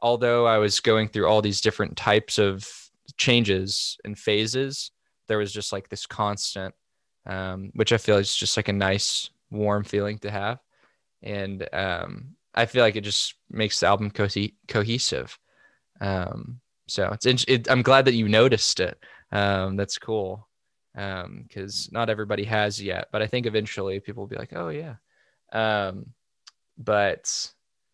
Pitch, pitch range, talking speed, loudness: 105 Hz, 100-115 Hz, 160 wpm, -24 LUFS